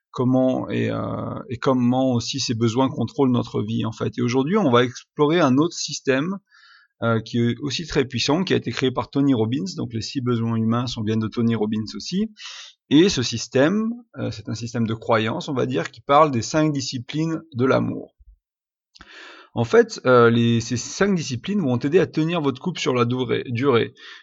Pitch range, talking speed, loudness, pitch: 115-150 Hz, 200 wpm, -21 LUFS, 125 Hz